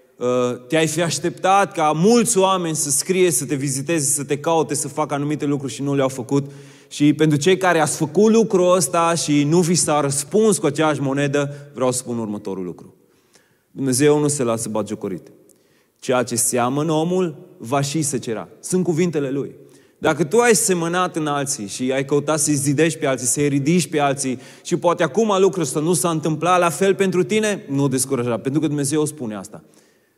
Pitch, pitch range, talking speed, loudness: 150 Hz, 135-175 Hz, 190 wpm, -19 LUFS